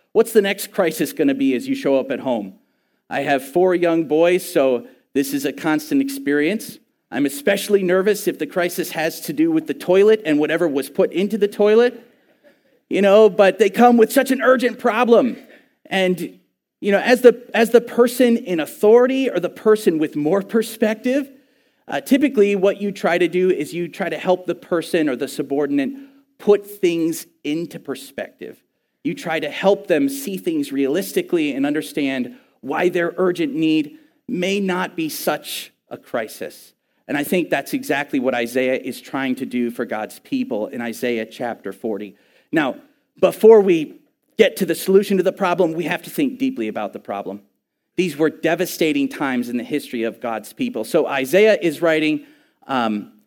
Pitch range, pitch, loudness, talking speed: 155-250 Hz, 190 Hz, -19 LUFS, 180 wpm